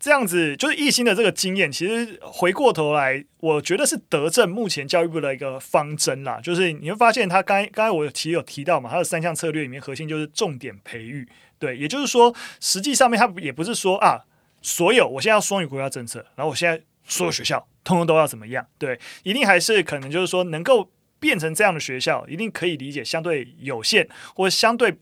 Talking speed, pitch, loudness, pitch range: 345 characters per minute, 170 Hz, -21 LUFS, 150-210 Hz